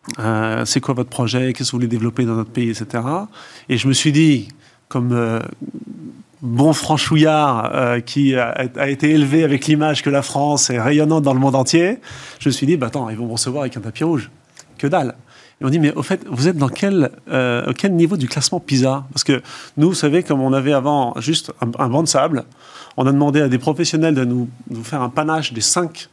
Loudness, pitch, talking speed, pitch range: -17 LUFS, 140 Hz, 235 wpm, 125-155 Hz